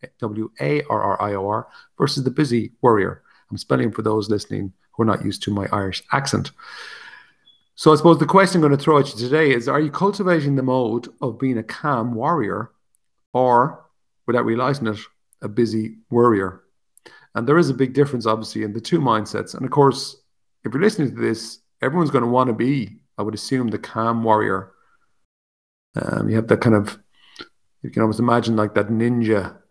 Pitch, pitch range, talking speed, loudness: 120 Hz, 110-135 Hz, 185 wpm, -20 LUFS